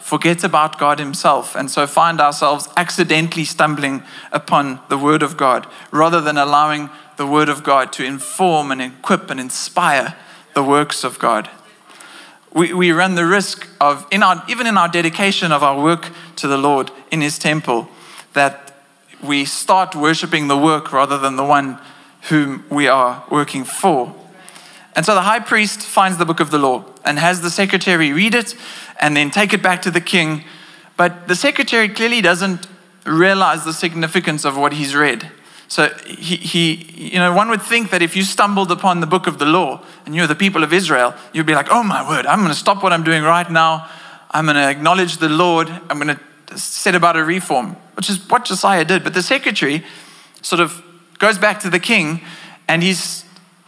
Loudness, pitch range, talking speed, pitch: -15 LUFS, 145-185 Hz, 195 wpm, 165 Hz